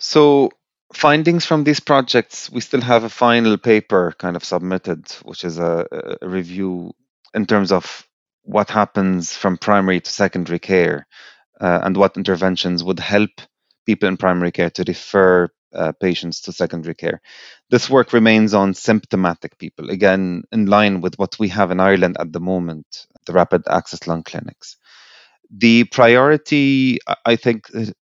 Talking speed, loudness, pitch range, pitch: 155 wpm, -17 LUFS, 90-115 Hz, 95 Hz